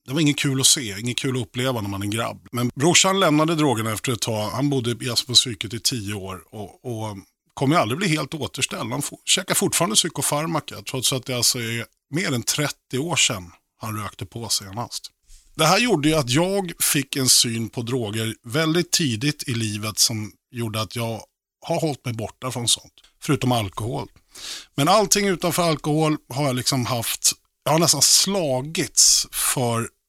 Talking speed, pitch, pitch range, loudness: 185 wpm, 125 Hz, 115-150 Hz, -21 LUFS